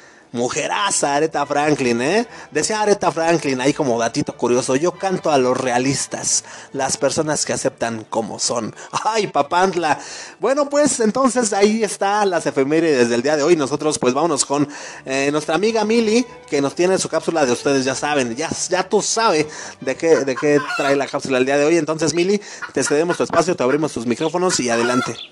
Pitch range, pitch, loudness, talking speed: 135-185 Hz, 150 Hz, -18 LUFS, 190 wpm